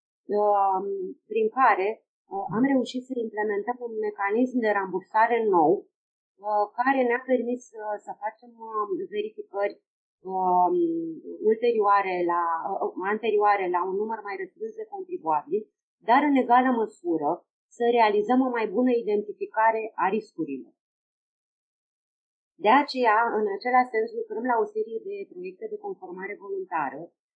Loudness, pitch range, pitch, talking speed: -25 LUFS, 205-350 Hz, 230 Hz, 115 wpm